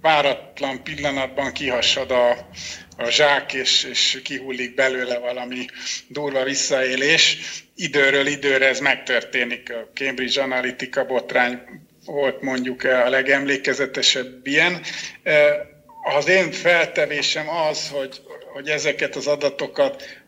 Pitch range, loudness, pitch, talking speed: 130-145 Hz, -20 LUFS, 135 Hz, 105 wpm